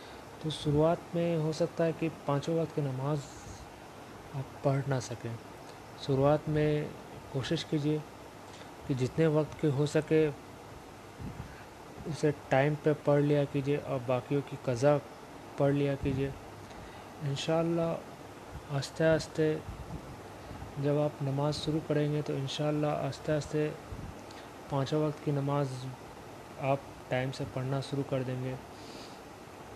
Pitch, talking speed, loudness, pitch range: 145 Hz, 115 wpm, -32 LUFS, 135-155 Hz